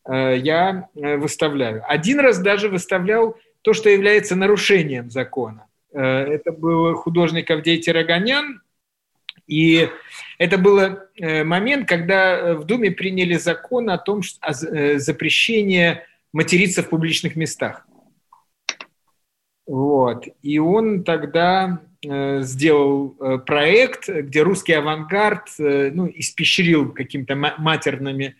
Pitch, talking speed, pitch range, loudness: 165 Hz, 95 wpm, 150-190 Hz, -18 LUFS